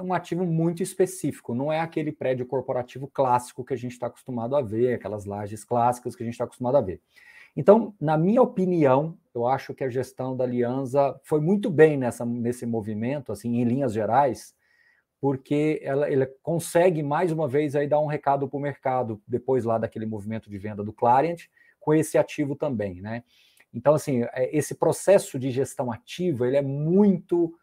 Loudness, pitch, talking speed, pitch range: -25 LUFS, 135 Hz, 185 wpm, 120-155 Hz